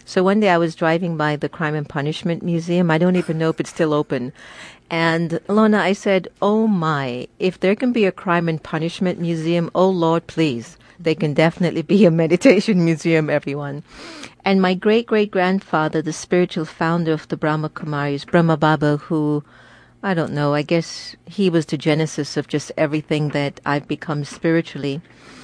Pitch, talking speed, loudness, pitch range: 165 Hz, 180 wpm, -19 LUFS, 150-180 Hz